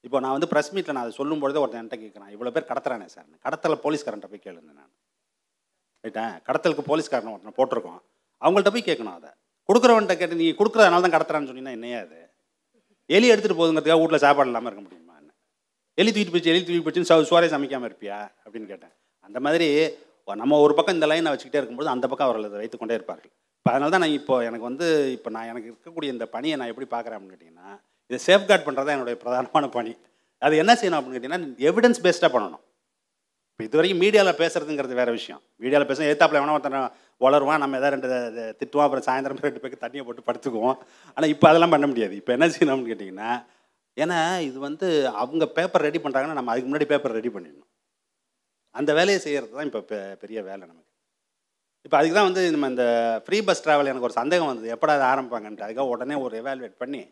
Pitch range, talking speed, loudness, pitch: 120-165 Hz, 190 wpm, -22 LUFS, 140 Hz